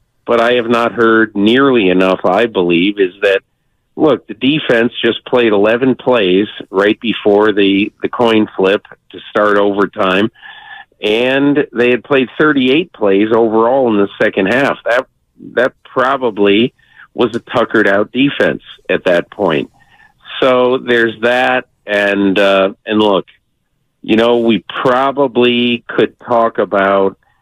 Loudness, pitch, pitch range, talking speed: -12 LUFS, 115 Hz, 100-125 Hz, 140 wpm